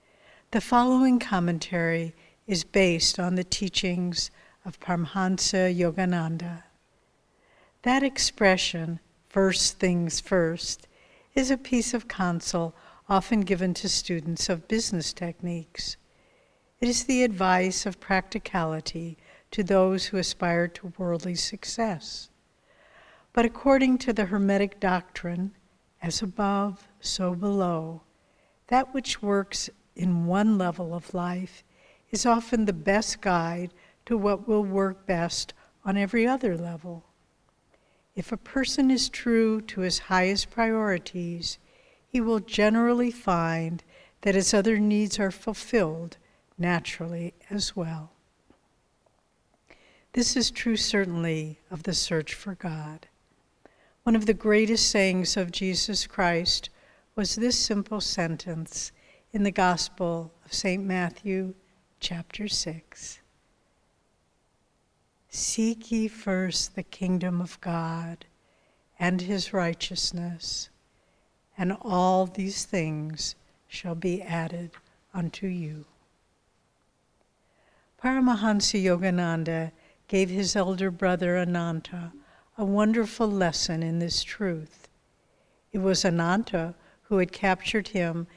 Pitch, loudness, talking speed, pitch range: 185 Hz, -27 LUFS, 110 wpm, 175-210 Hz